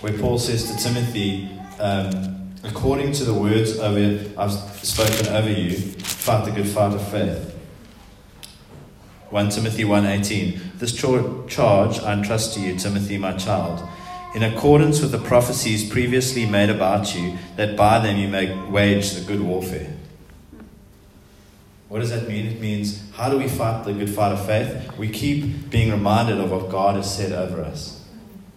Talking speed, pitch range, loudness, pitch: 160 wpm, 100-115 Hz, -21 LUFS, 105 Hz